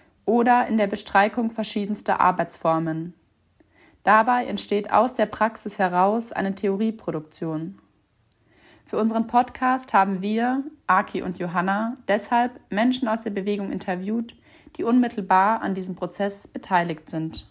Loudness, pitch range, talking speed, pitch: -23 LUFS, 185-230 Hz, 120 wpm, 205 Hz